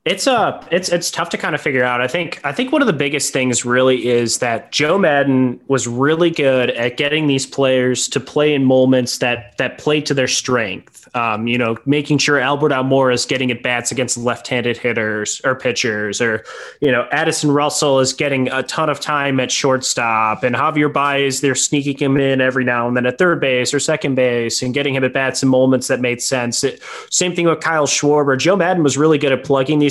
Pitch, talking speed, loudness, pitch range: 135 Hz, 225 wpm, -16 LUFS, 125-145 Hz